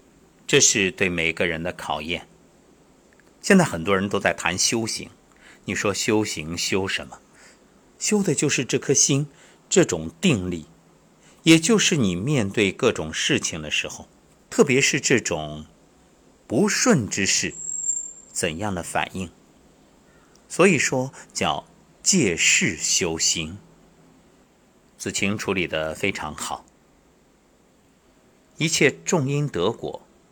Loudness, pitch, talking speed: -21 LUFS, 105 Hz, 170 characters per minute